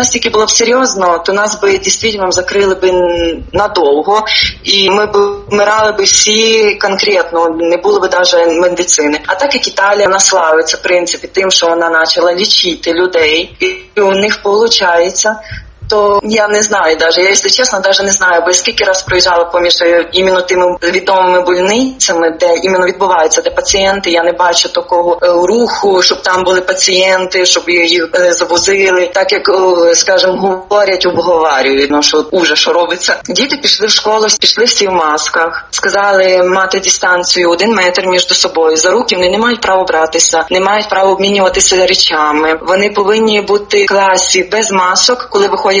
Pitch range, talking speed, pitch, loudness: 175-205 Hz, 165 wpm, 185 Hz, -9 LUFS